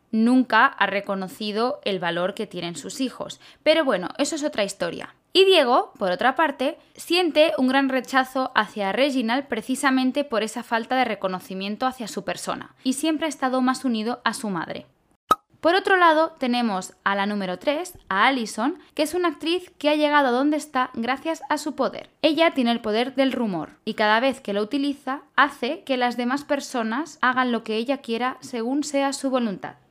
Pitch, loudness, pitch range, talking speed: 260 Hz, -23 LUFS, 220-290 Hz, 190 wpm